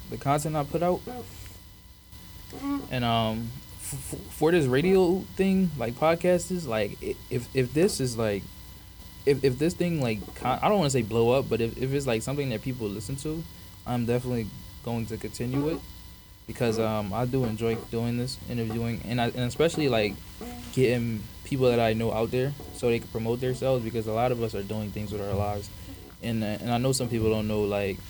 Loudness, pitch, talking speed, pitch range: -28 LUFS, 115 Hz, 205 wpm, 105-135 Hz